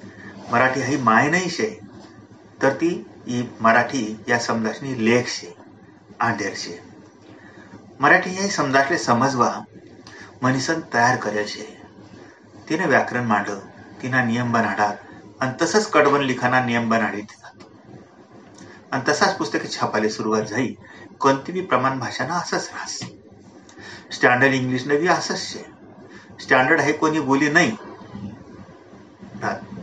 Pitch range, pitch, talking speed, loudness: 110-135 Hz, 125 Hz, 100 wpm, -20 LUFS